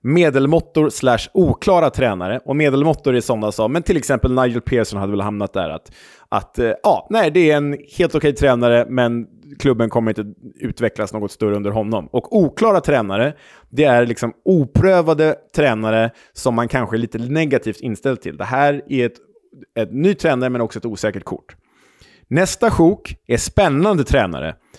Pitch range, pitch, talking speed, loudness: 110-145 Hz, 125 Hz, 170 wpm, -17 LUFS